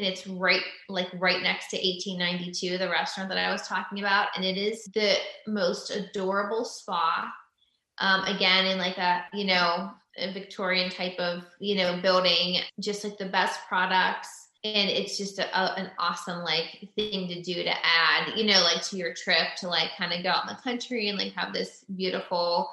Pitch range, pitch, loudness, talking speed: 180-200 Hz, 185 Hz, -26 LUFS, 195 wpm